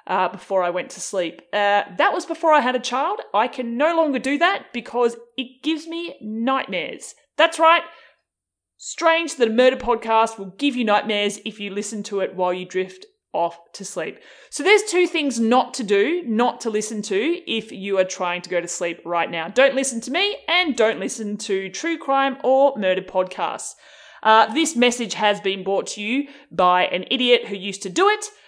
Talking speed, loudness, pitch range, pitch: 205 wpm, -21 LUFS, 195-285 Hz, 235 Hz